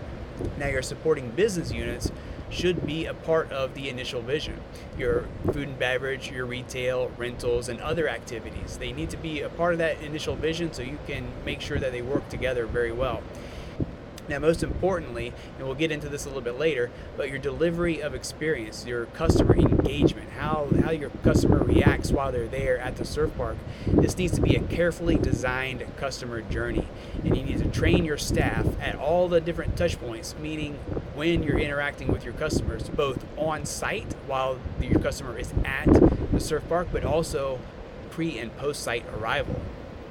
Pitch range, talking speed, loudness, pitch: 120-160 Hz, 185 wpm, -27 LUFS, 135 Hz